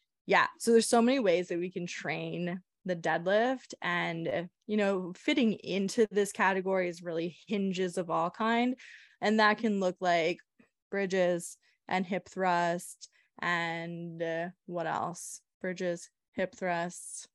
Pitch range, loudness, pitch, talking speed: 175-205 Hz, -31 LUFS, 185 Hz, 140 wpm